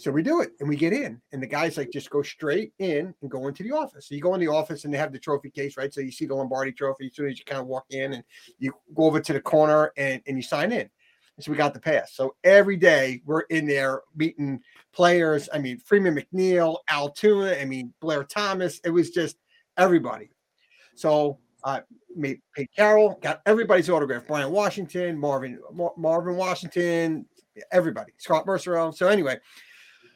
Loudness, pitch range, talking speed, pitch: -24 LUFS, 140-180 Hz, 215 wpm, 155 Hz